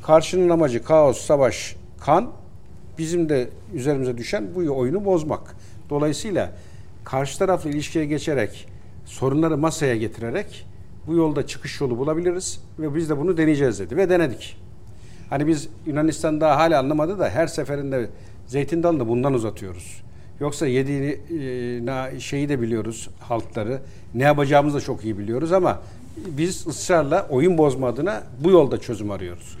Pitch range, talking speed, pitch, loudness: 115-155 Hz, 140 wpm, 140 Hz, -22 LUFS